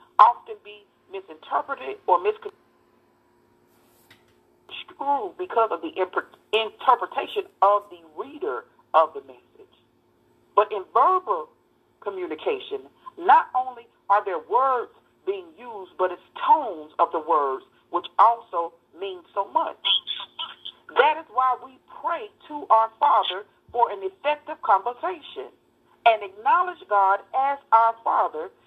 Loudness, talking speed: -23 LUFS, 115 wpm